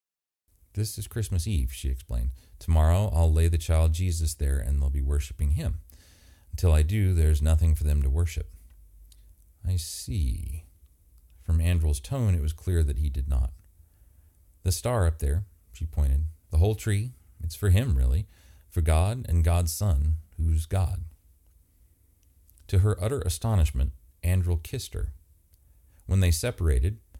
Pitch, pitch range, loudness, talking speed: 80 Hz, 75-90 Hz, -27 LUFS, 150 wpm